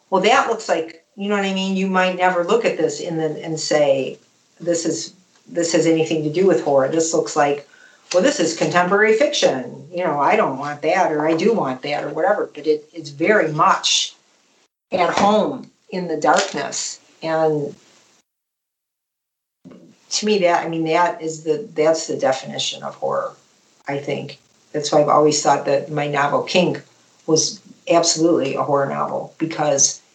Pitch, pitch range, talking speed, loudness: 160 Hz, 150-180 Hz, 180 wpm, -19 LUFS